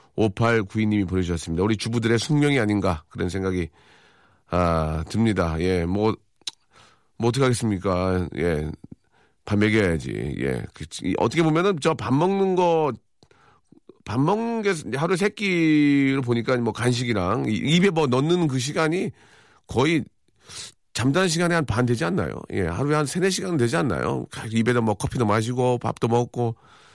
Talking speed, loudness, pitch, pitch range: 295 characters per minute, -23 LUFS, 120 Hz, 105-150 Hz